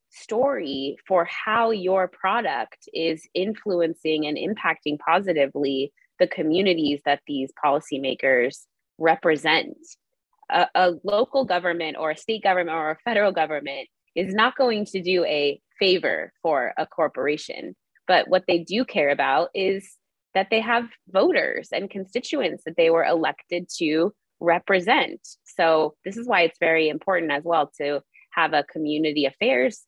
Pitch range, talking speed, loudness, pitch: 155-195 Hz, 145 wpm, -23 LUFS, 175 Hz